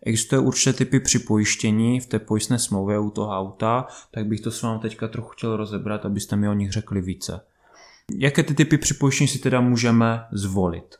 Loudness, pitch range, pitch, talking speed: -22 LUFS, 105-125 Hz, 110 Hz, 185 wpm